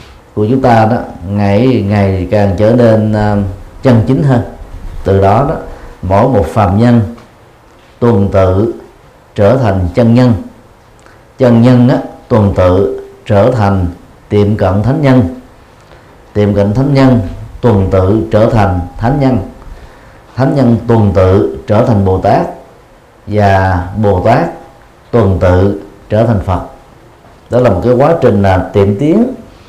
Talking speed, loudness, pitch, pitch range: 145 wpm, -10 LUFS, 105 Hz, 95-120 Hz